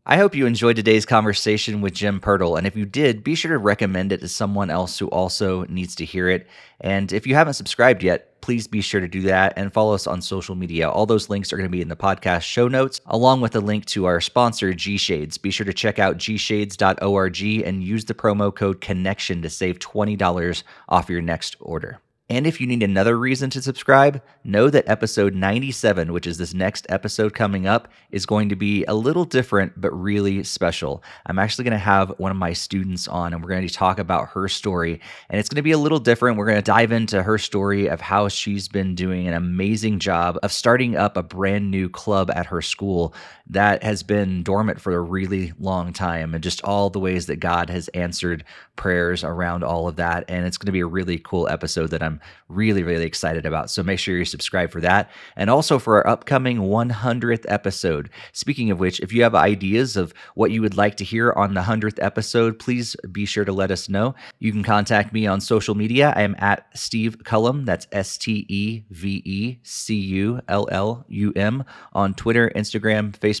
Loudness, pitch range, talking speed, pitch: -21 LUFS, 90-110 Hz, 215 wpm, 100 Hz